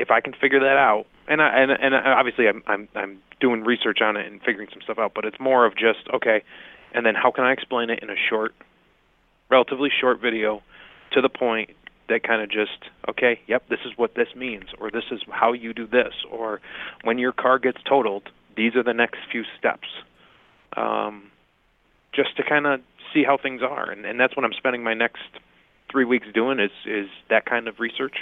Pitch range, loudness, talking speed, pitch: 115-130 Hz, -22 LUFS, 215 wpm, 120 Hz